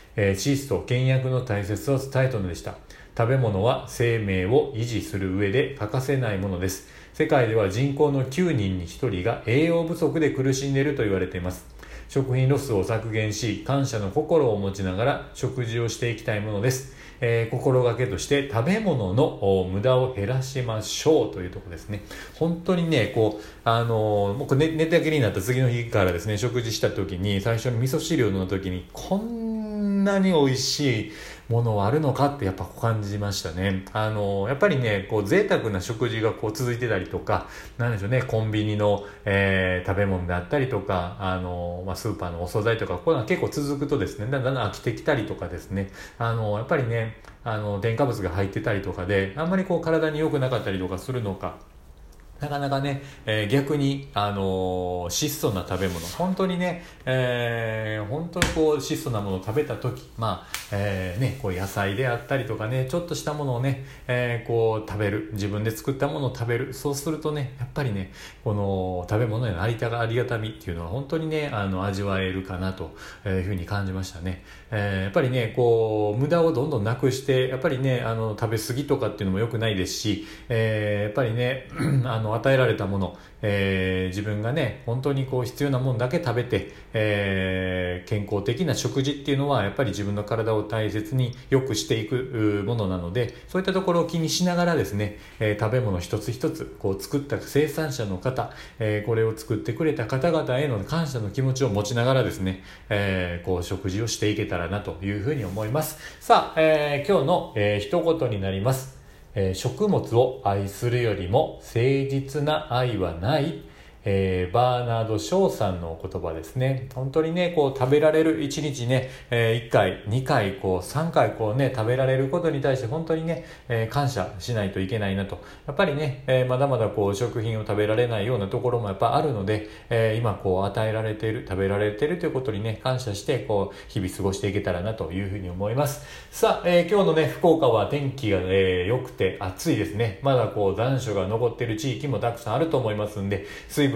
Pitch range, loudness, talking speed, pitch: 100-135 Hz, -25 LUFS, 385 characters per minute, 115 Hz